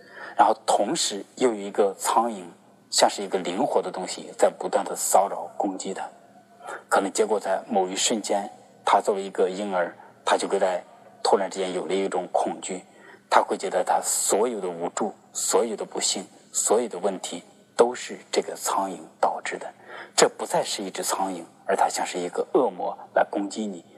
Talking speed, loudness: 270 characters per minute, -25 LUFS